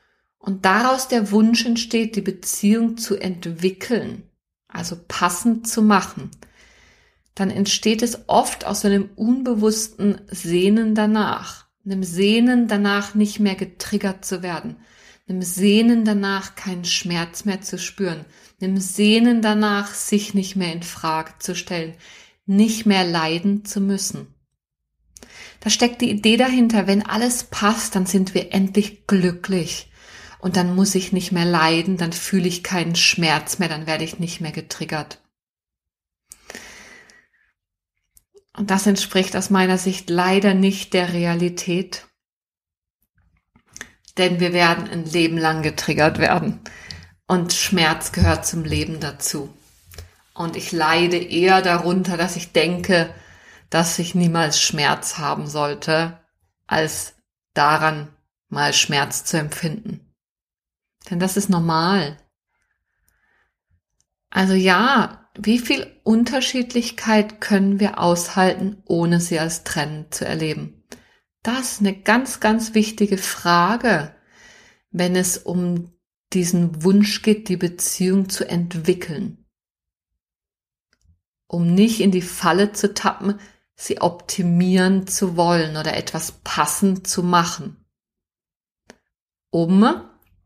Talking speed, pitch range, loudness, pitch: 120 wpm, 170-205 Hz, -19 LUFS, 185 Hz